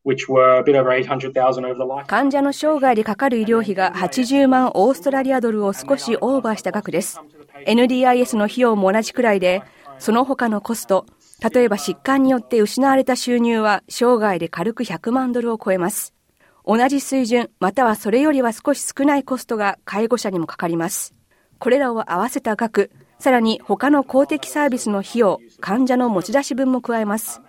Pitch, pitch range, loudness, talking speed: 230 Hz, 195-260 Hz, -18 LUFS, 340 characters per minute